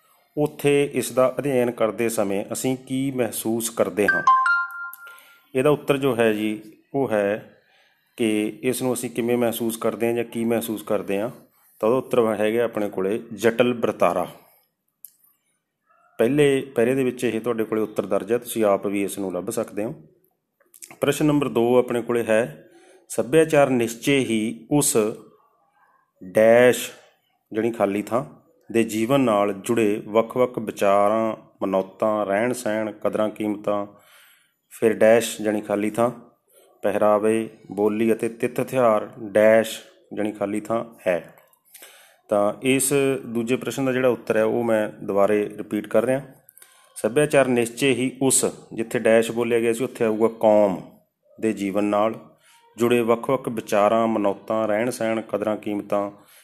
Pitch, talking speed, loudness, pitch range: 115 Hz, 135 wpm, -22 LUFS, 105-125 Hz